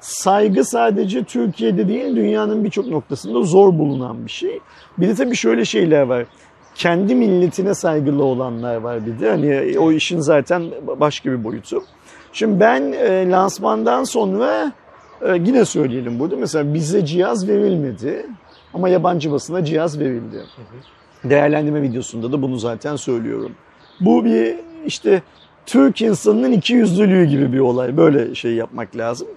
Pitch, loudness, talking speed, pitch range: 160 Hz, -17 LUFS, 135 wpm, 130-205 Hz